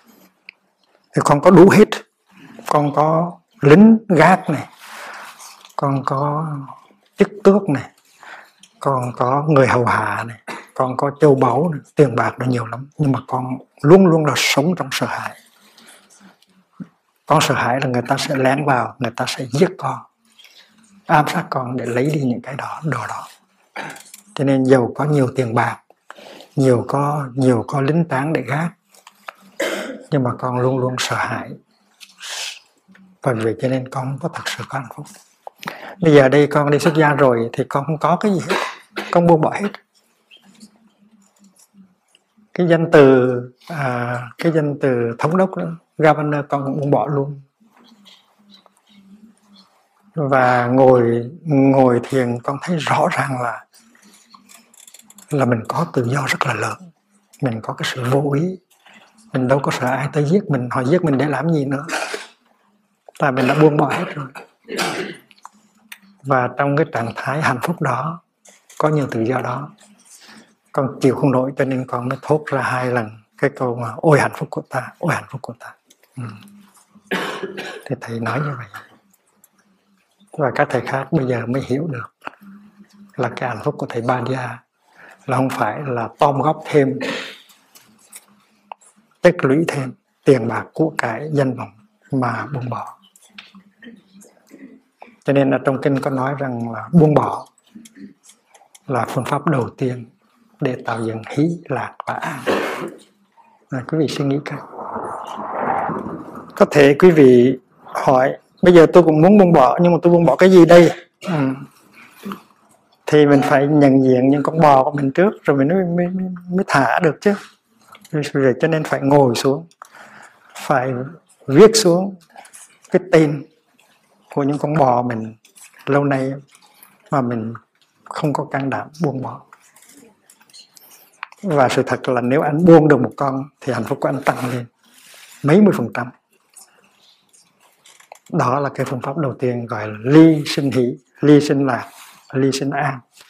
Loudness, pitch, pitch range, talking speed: -17 LUFS, 145 Hz, 130-175 Hz, 165 wpm